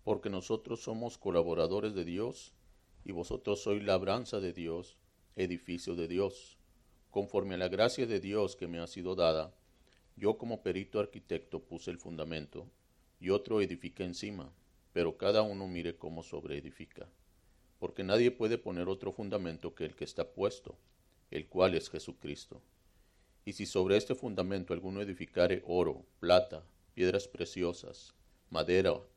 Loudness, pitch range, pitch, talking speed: -35 LUFS, 85-100 Hz, 90 Hz, 145 wpm